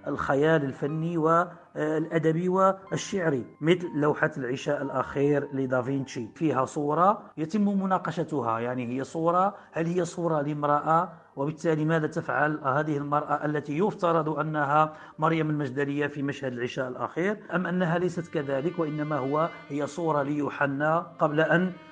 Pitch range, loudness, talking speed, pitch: 145-170 Hz, -27 LUFS, 125 wpm, 155 Hz